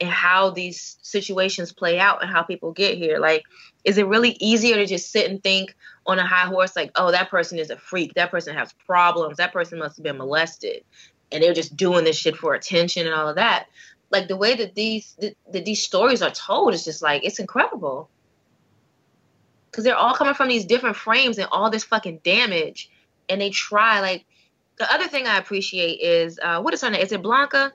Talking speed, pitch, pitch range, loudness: 220 wpm, 190 Hz, 170-220 Hz, -20 LUFS